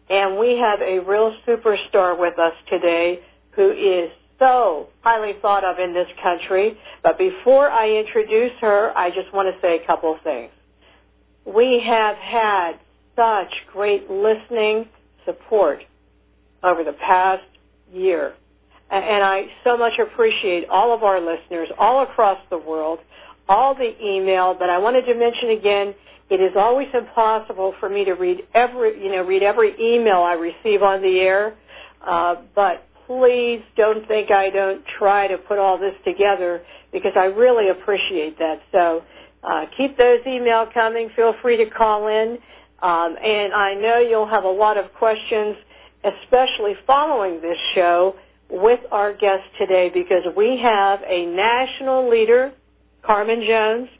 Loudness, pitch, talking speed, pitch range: -18 LUFS, 205 Hz, 155 wpm, 185-235 Hz